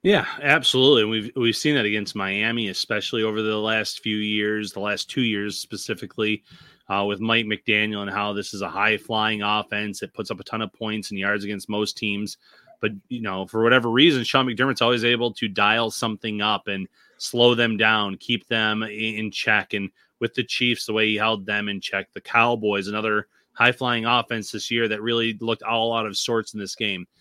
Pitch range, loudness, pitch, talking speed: 105-115 Hz, -22 LUFS, 110 Hz, 210 wpm